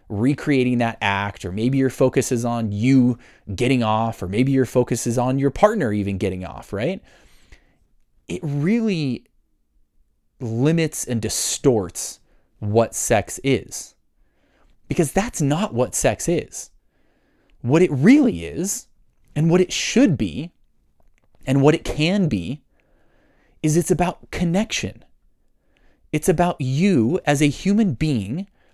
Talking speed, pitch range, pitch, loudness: 130 wpm, 115-165 Hz, 130 Hz, -20 LUFS